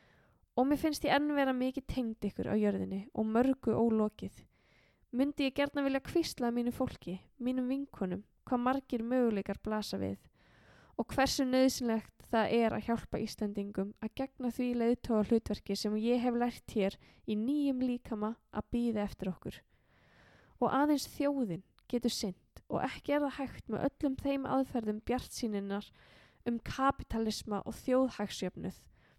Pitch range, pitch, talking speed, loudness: 215-265 Hz, 240 Hz, 150 wpm, -34 LUFS